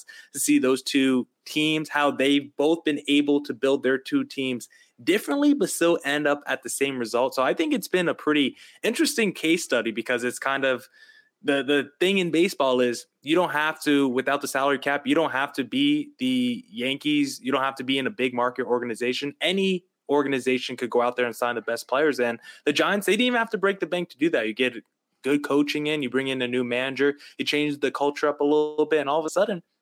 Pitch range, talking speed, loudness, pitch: 130-170 Hz, 235 wpm, -24 LUFS, 145 Hz